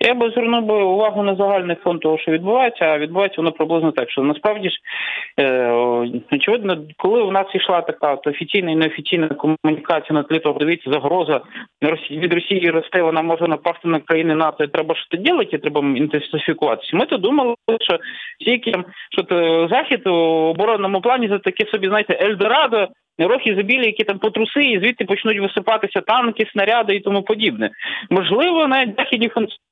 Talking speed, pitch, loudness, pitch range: 170 wpm, 190 Hz, -18 LUFS, 160-220 Hz